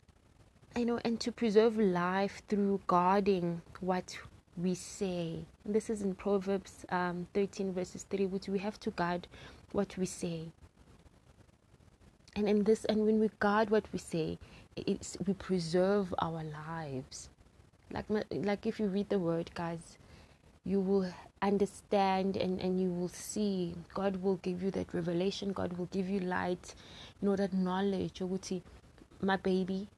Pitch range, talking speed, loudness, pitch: 175-200 Hz, 160 wpm, -34 LUFS, 190 Hz